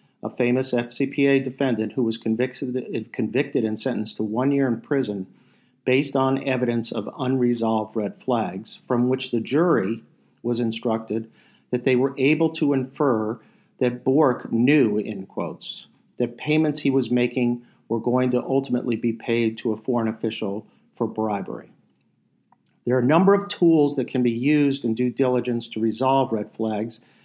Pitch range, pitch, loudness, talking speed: 115-135 Hz, 125 Hz, -23 LUFS, 160 wpm